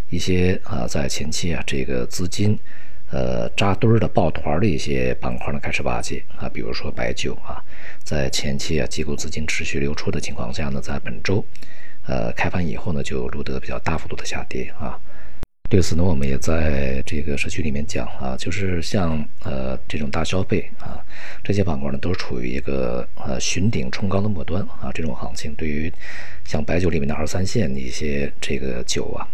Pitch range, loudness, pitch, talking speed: 70-90 Hz, -24 LUFS, 75 Hz, 290 characters per minute